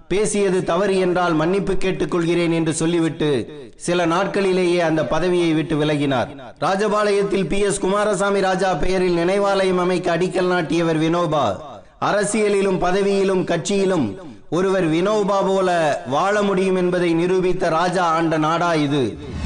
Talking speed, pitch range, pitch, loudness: 115 wpm, 170-195 Hz, 180 Hz, -19 LUFS